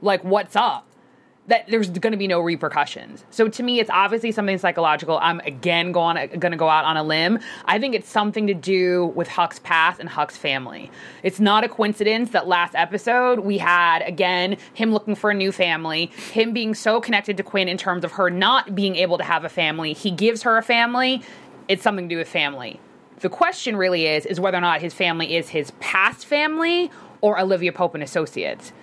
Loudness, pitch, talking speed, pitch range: -20 LUFS, 195 Hz, 210 wpm, 170-225 Hz